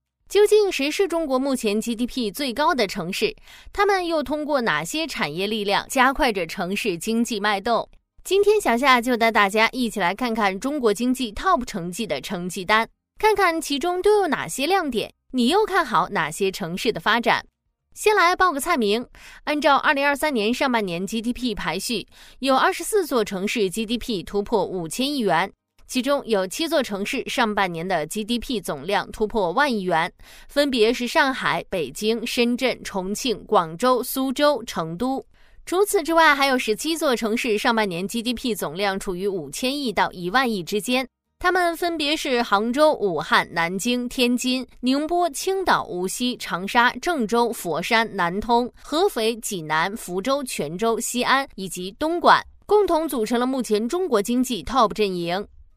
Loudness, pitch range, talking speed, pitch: -22 LUFS, 205-290 Hz, 265 characters per minute, 240 Hz